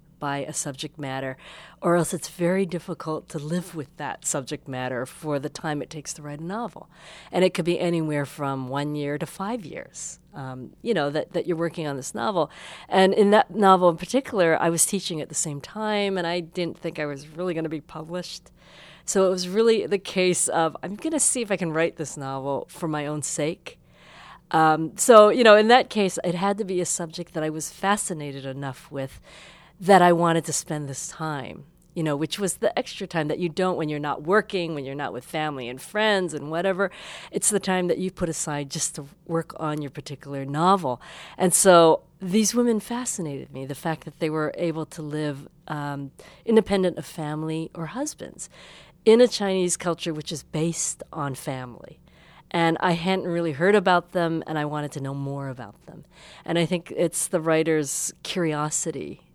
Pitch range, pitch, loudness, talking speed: 150-185 Hz, 165 Hz, -24 LUFS, 205 wpm